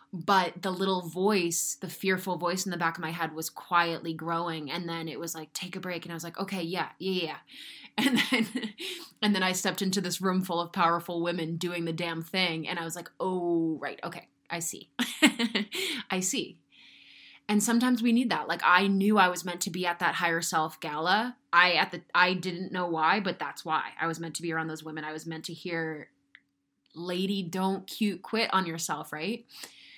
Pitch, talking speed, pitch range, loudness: 180 Hz, 215 wpm, 165-195 Hz, -29 LUFS